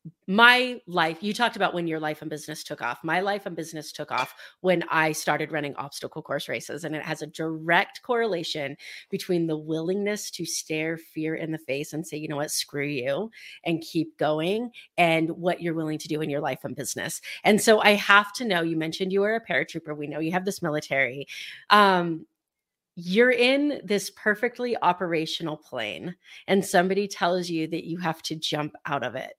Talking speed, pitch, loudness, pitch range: 200 wpm, 165 Hz, -25 LUFS, 155-195 Hz